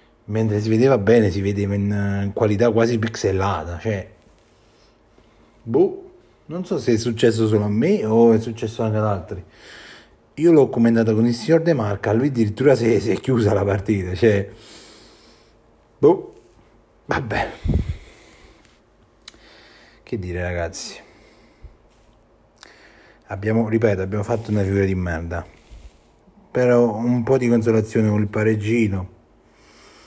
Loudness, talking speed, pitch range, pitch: -20 LUFS, 125 wpm, 100-115 Hz, 110 Hz